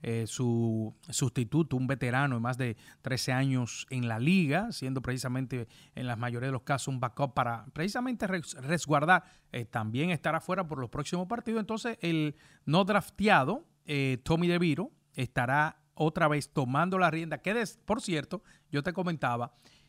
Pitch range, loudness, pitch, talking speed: 130-175 Hz, -31 LUFS, 145 Hz, 165 wpm